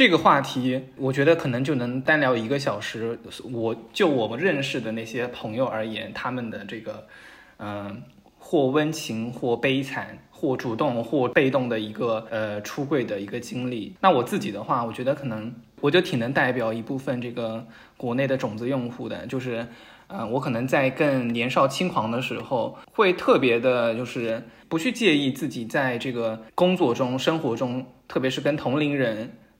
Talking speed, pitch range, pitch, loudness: 270 characters per minute, 115-135 Hz, 125 Hz, -25 LUFS